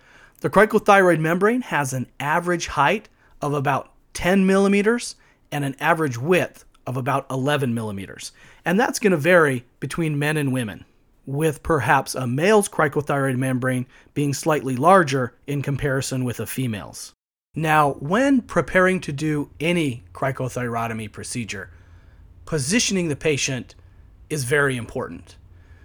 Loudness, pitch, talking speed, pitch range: -21 LUFS, 140 Hz, 130 wpm, 125-170 Hz